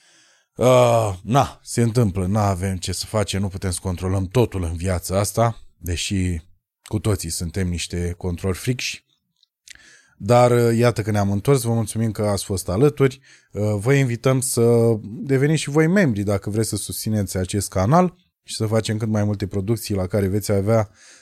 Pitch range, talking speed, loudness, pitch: 95-120 Hz, 175 wpm, -21 LUFS, 105 Hz